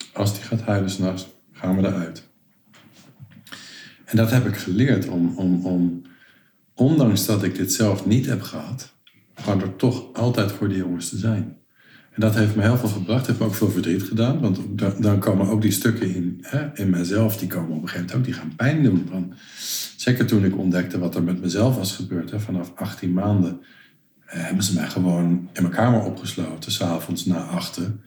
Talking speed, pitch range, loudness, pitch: 200 wpm, 90-110 Hz, -22 LUFS, 100 Hz